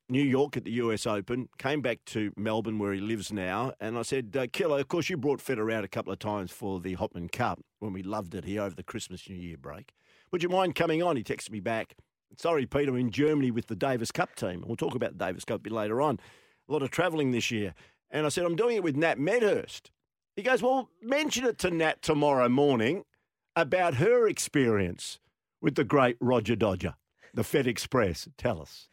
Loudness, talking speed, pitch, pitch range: -29 LUFS, 230 wpm, 120 Hz, 105-150 Hz